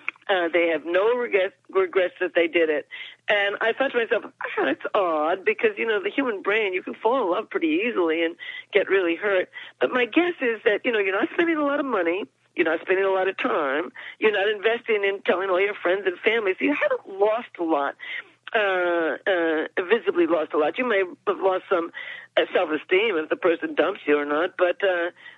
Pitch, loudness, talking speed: 210 Hz, -23 LUFS, 220 wpm